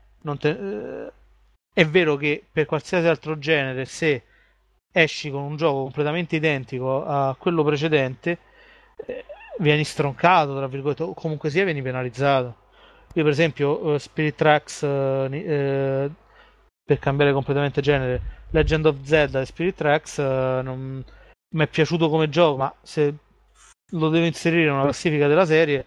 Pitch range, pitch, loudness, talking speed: 135-160 Hz, 150 Hz, -22 LUFS, 145 wpm